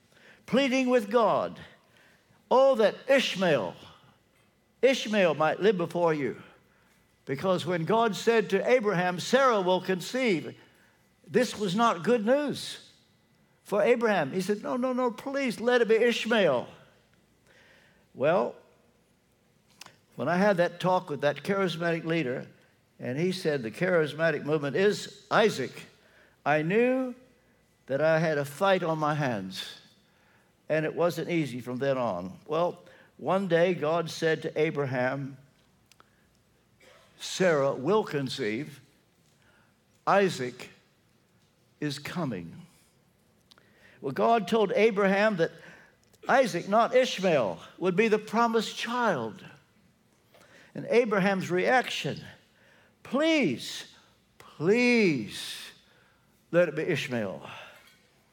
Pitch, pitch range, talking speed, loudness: 190 Hz, 160-230 Hz, 110 wpm, -27 LUFS